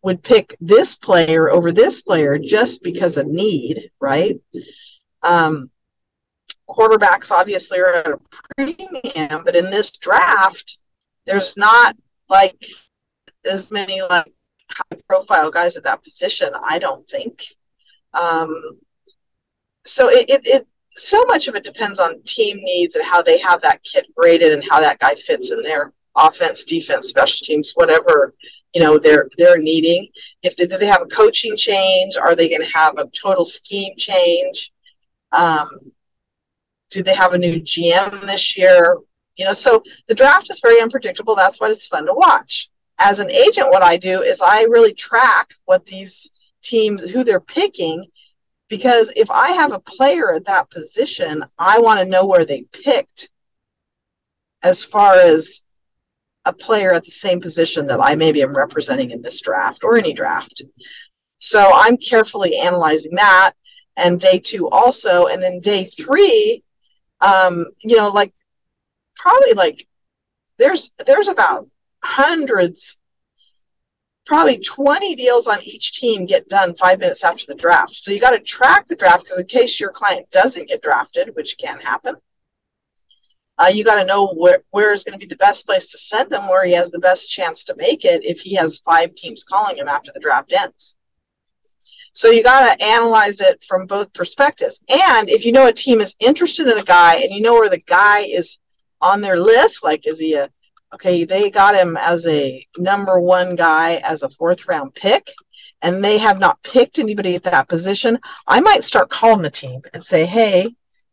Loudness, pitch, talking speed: -14 LUFS, 215 Hz, 175 wpm